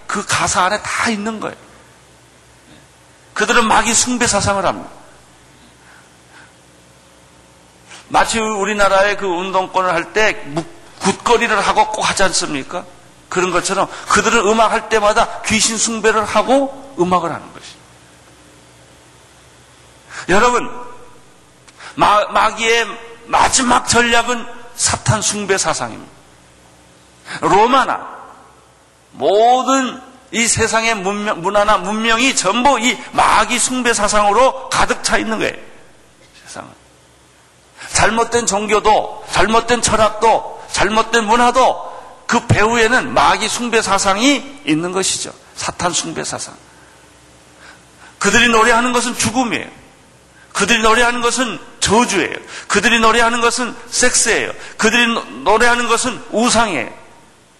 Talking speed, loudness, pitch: 245 characters per minute, -14 LUFS, 210 Hz